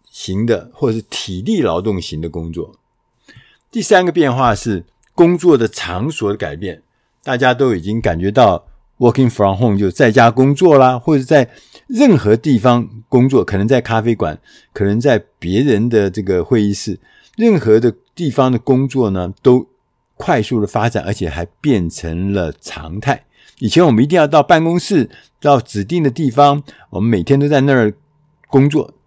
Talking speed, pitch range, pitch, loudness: 275 characters per minute, 100-140 Hz, 120 Hz, -14 LUFS